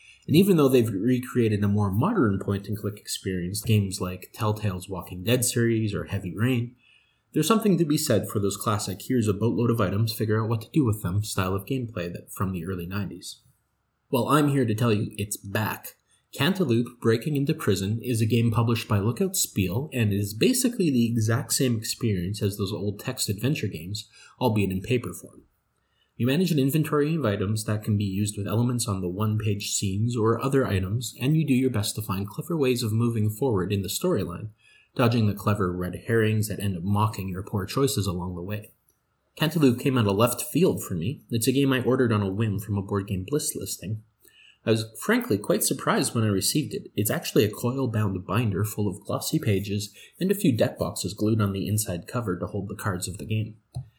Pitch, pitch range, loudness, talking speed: 110 Hz, 100-120 Hz, -26 LUFS, 210 wpm